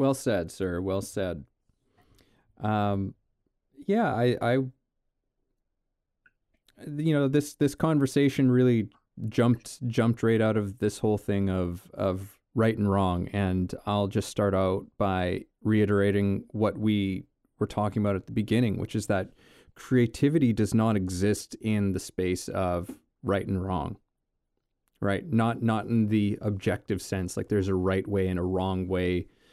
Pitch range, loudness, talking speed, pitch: 95-115 Hz, -27 LUFS, 150 wpm, 105 Hz